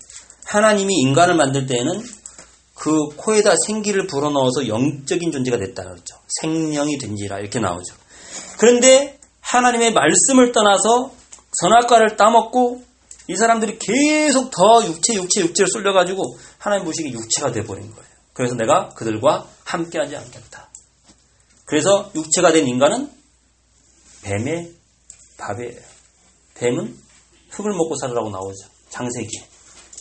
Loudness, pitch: -17 LUFS, 165 Hz